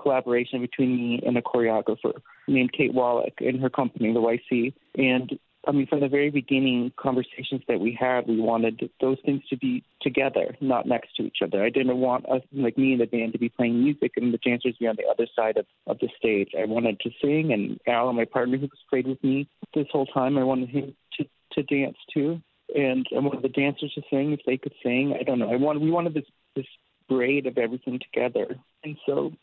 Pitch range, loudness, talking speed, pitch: 120-140 Hz, -25 LUFS, 230 wpm, 130 Hz